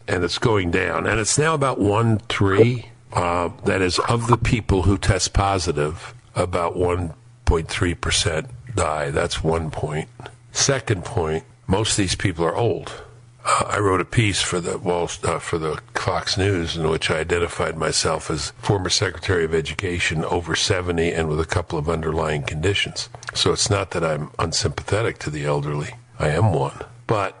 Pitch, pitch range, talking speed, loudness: 95 Hz, 85-115 Hz, 175 wpm, -21 LUFS